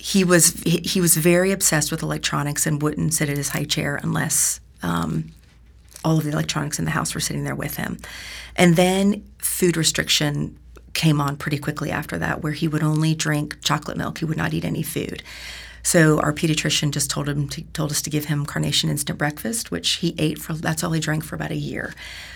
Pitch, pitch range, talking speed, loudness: 150 Hz, 140-165 Hz, 210 wpm, -21 LUFS